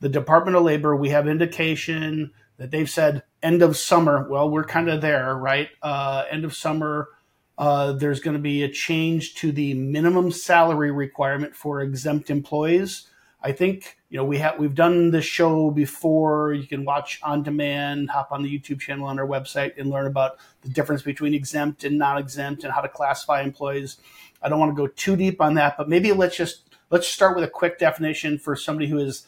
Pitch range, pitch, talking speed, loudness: 140-160 Hz, 150 Hz, 205 wpm, -22 LUFS